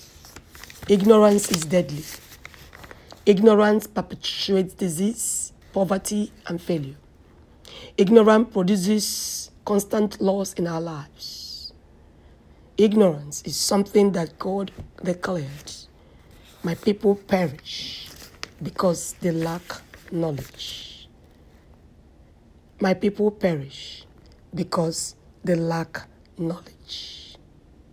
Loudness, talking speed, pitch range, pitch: -23 LUFS, 75 wpm, 135-200 Hz, 175 Hz